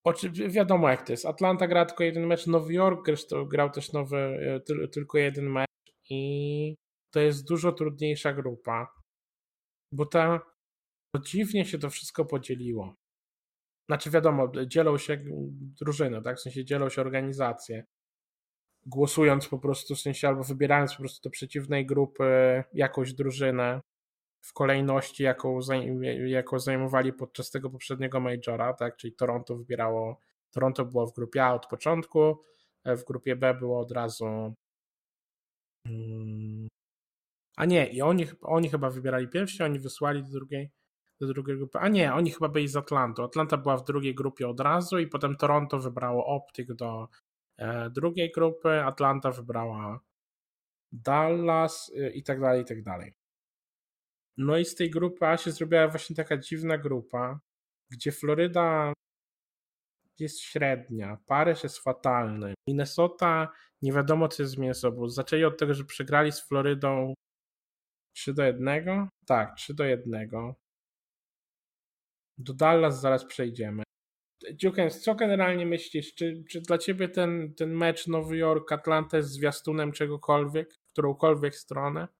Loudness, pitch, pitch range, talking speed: -28 LUFS, 140 Hz, 130-160 Hz, 140 wpm